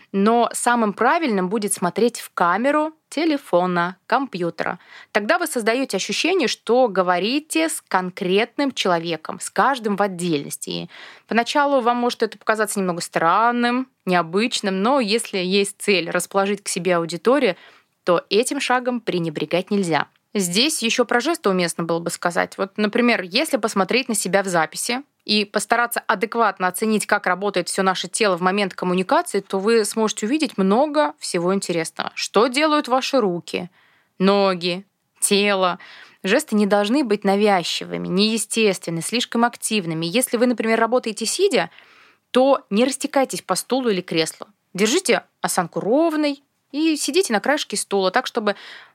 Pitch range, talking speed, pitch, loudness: 185-245 Hz, 140 wpm, 210 Hz, -20 LUFS